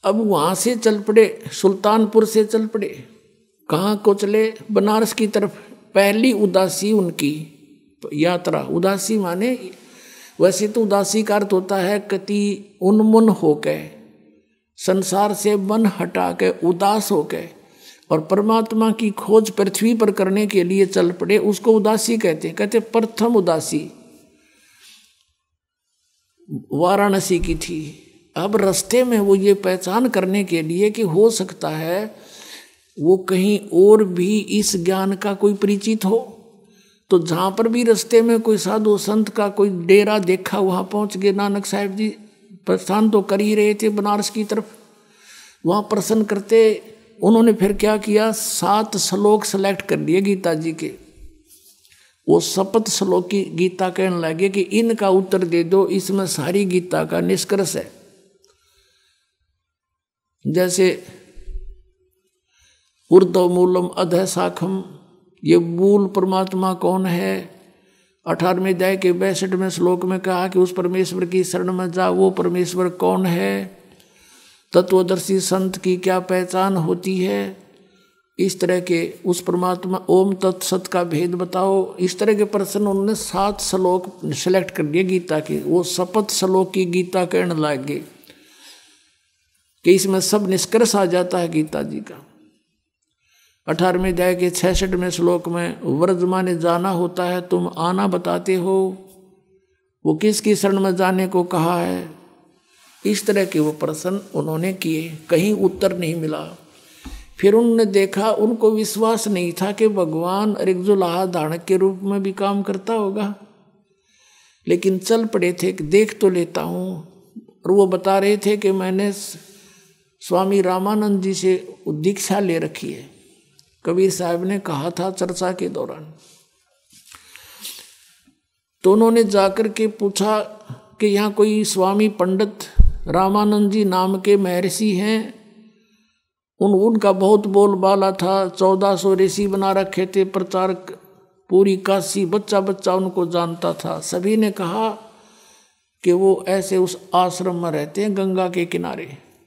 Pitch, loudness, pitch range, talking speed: 195 Hz, -18 LUFS, 180-210 Hz, 140 wpm